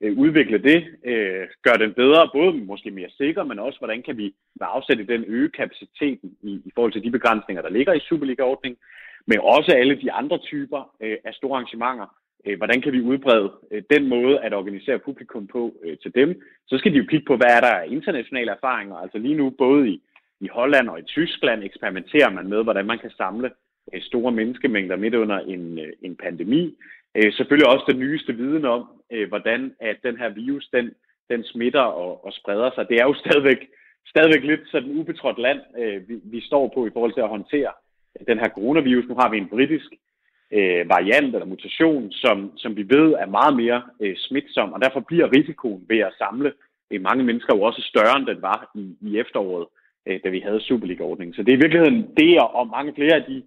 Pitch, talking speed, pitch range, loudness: 125 Hz, 190 wpm, 110-150 Hz, -20 LUFS